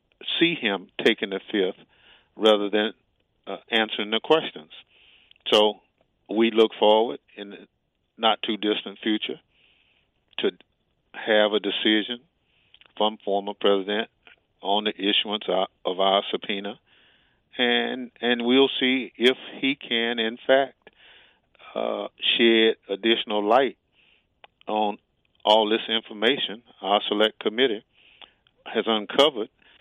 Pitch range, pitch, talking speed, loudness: 105-115 Hz, 110 Hz, 115 wpm, -23 LUFS